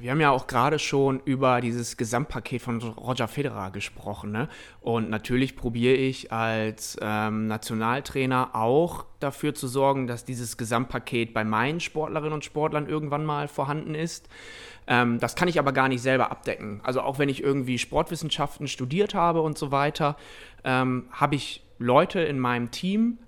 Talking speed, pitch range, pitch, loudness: 165 wpm, 120-150 Hz, 130 Hz, -26 LUFS